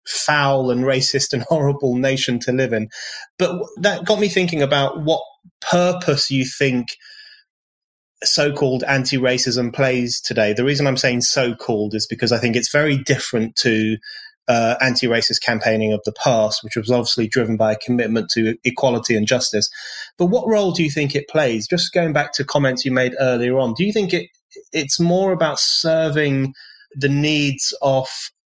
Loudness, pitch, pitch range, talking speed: -18 LUFS, 135 Hz, 120-160 Hz, 170 wpm